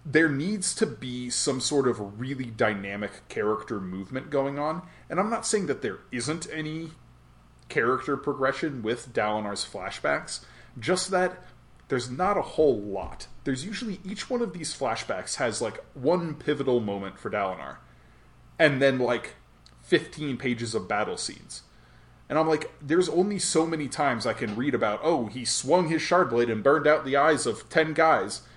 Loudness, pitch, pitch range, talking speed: -27 LUFS, 140 Hz, 115-160 Hz, 170 wpm